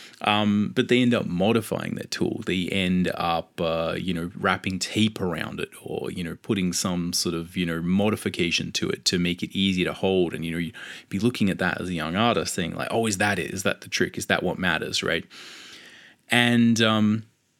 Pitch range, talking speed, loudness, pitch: 85-110 Hz, 220 wpm, -24 LUFS, 95 Hz